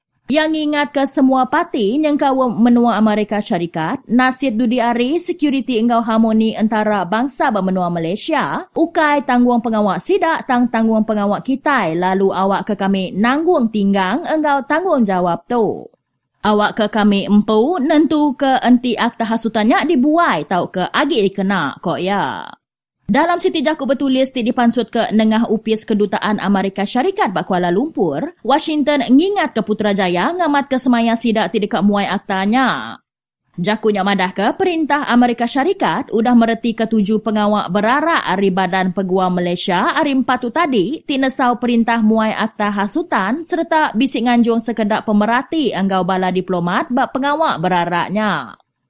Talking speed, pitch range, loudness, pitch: 145 wpm, 205-280 Hz, -16 LUFS, 230 Hz